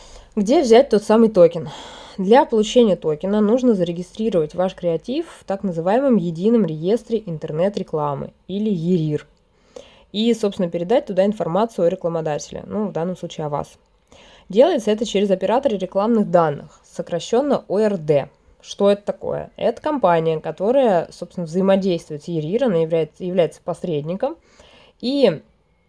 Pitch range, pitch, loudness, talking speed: 170-225 Hz, 195 Hz, -19 LUFS, 130 wpm